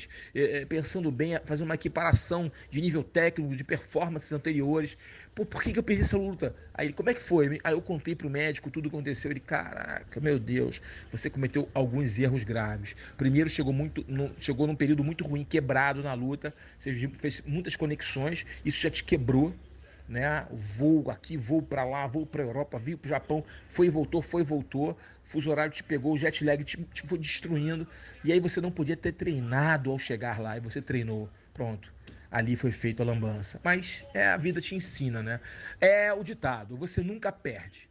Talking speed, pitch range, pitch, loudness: 190 wpm, 130-165 Hz, 150 Hz, -30 LUFS